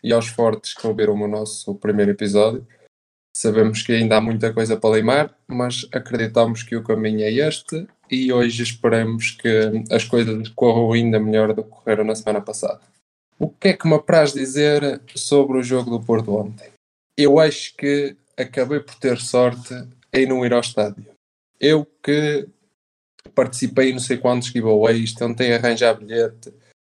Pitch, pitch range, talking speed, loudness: 120 Hz, 110-130 Hz, 170 wpm, -19 LUFS